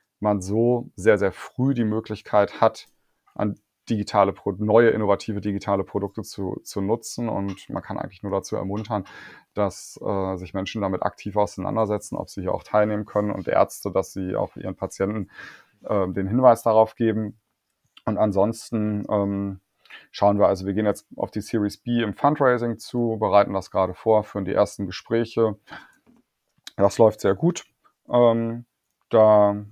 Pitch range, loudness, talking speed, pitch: 100-110 Hz, -23 LUFS, 160 wpm, 105 Hz